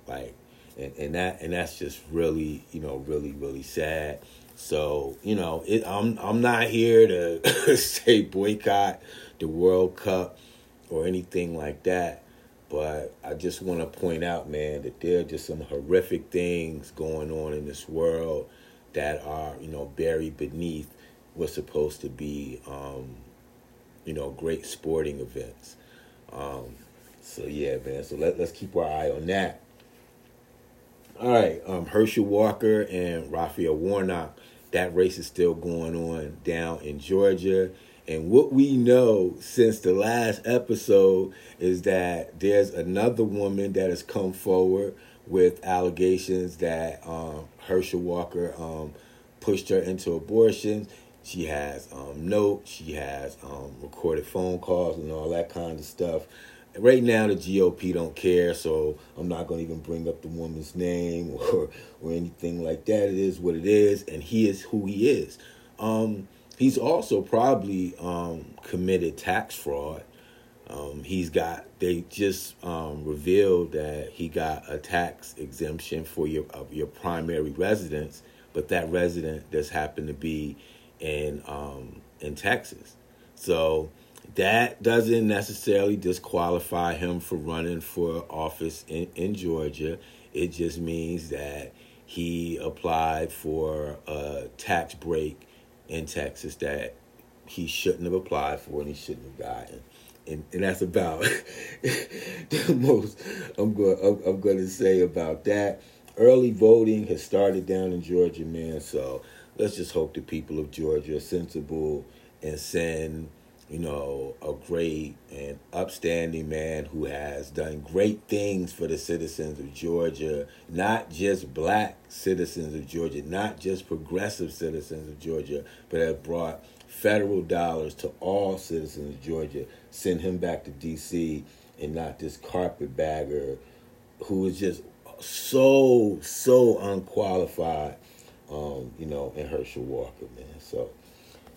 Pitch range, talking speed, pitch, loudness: 75-95 Hz, 145 wpm, 85 Hz, -27 LUFS